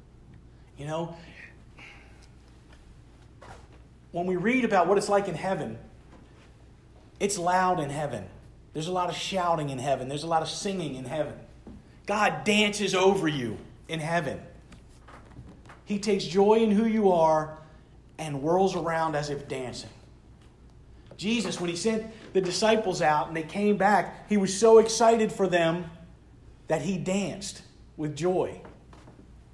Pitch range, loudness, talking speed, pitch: 150-195 Hz, -26 LUFS, 140 wpm, 175 Hz